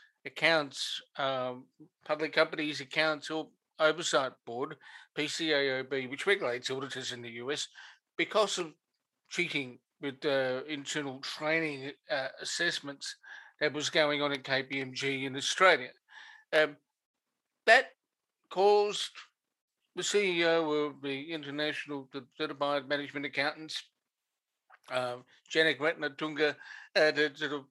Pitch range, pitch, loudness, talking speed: 135-160 Hz, 150 Hz, -31 LUFS, 110 wpm